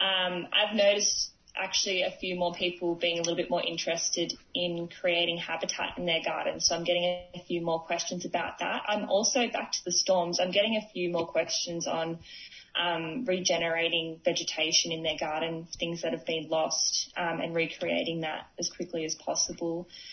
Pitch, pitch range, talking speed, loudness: 170 Hz, 165-180 Hz, 180 wpm, -29 LUFS